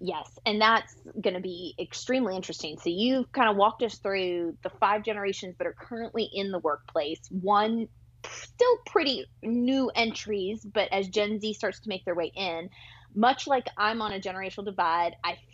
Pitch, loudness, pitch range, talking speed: 205 Hz, -28 LUFS, 180-225 Hz, 185 wpm